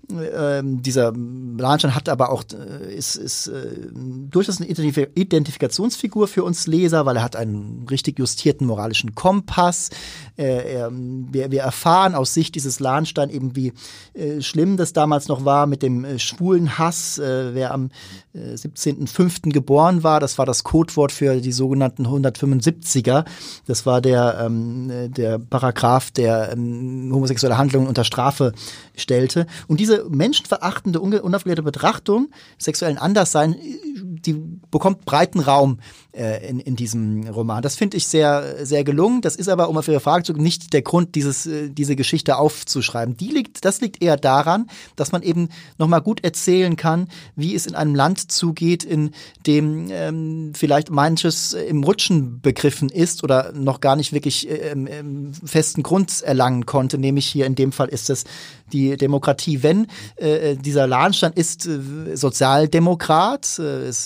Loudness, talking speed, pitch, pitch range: -19 LUFS, 160 wpm, 145 Hz, 130-165 Hz